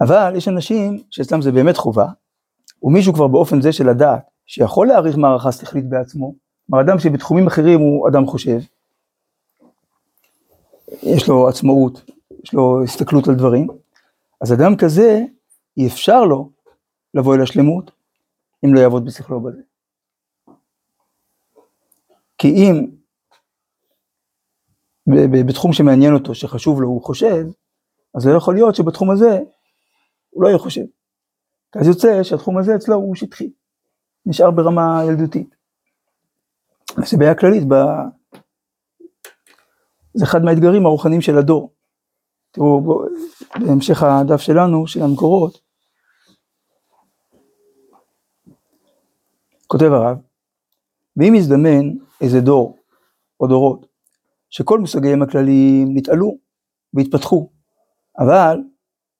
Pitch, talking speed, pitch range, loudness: 155 Hz, 110 wpm, 135-190 Hz, -14 LUFS